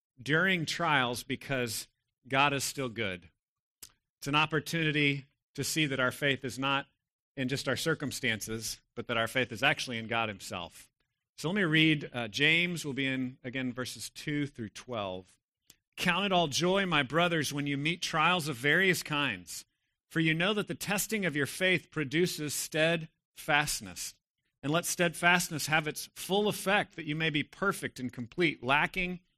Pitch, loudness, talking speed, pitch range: 145 Hz, -30 LUFS, 170 wpm, 125-165 Hz